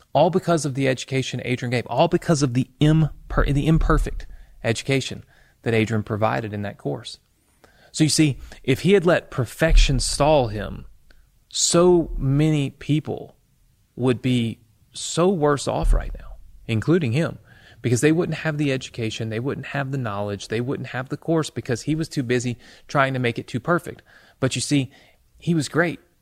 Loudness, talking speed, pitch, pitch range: -22 LUFS, 175 wpm, 135 Hz, 115-155 Hz